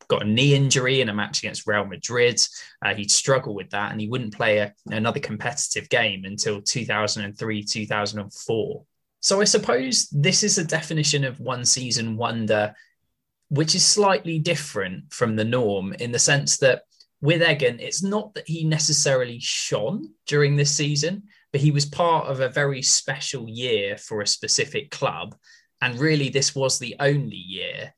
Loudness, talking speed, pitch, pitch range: -22 LUFS, 170 wpm, 140 Hz, 115-160 Hz